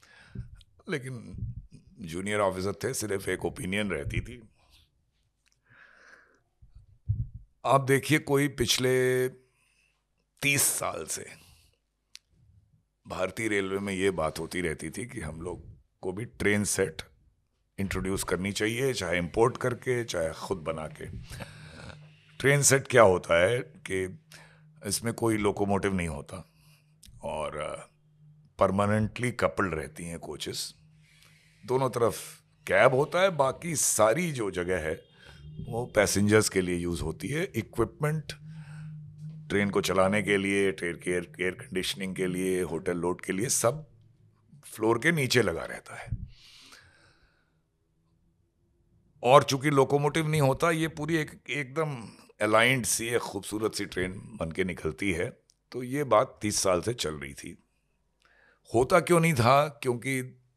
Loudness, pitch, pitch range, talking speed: -28 LUFS, 110 Hz, 95-140 Hz, 125 wpm